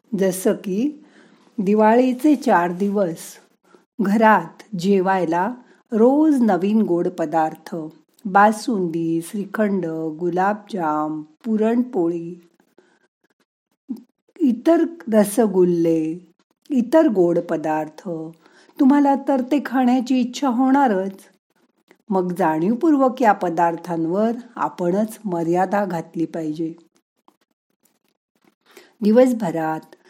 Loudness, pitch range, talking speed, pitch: -19 LUFS, 170-245 Hz, 70 wpm, 200 Hz